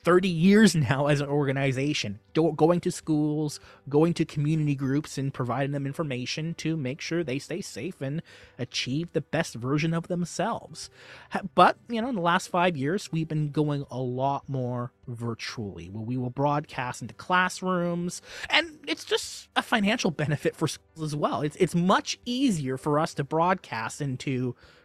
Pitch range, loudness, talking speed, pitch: 135-175 Hz, -27 LUFS, 170 wpm, 150 Hz